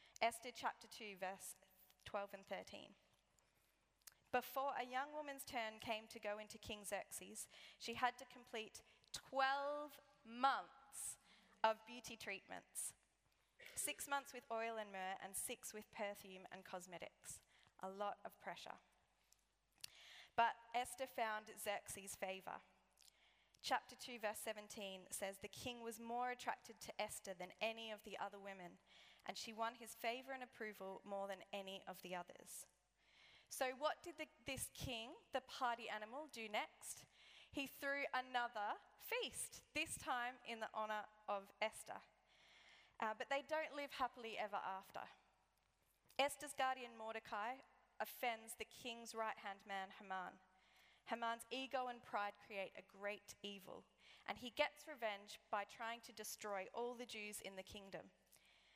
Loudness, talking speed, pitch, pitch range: -48 LUFS, 145 wpm, 225 Hz, 200-250 Hz